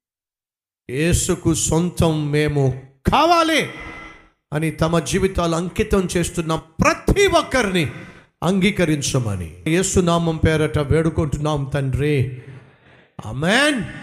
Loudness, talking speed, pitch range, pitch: -19 LUFS, 75 wpm, 135-175 Hz, 160 Hz